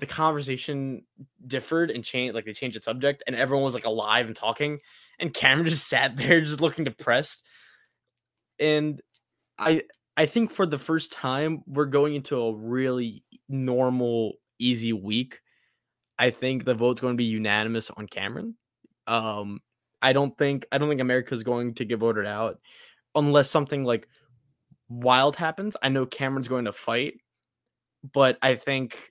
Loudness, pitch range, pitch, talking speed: -25 LUFS, 120-145 Hz, 130 Hz, 160 wpm